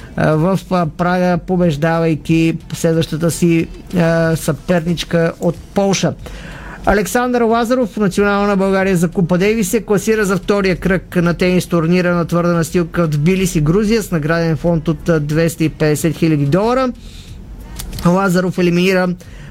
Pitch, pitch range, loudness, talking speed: 175 Hz, 165-190 Hz, -15 LUFS, 125 wpm